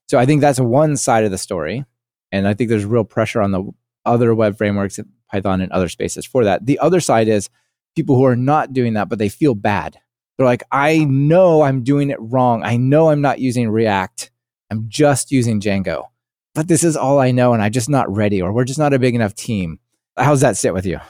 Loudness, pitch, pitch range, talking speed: -16 LUFS, 120 Hz, 105-140 Hz, 235 wpm